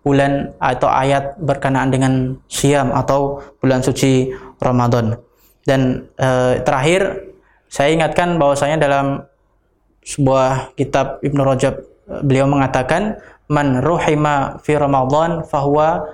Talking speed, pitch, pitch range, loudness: 105 wpm, 140 Hz, 130-150 Hz, -16 LUFS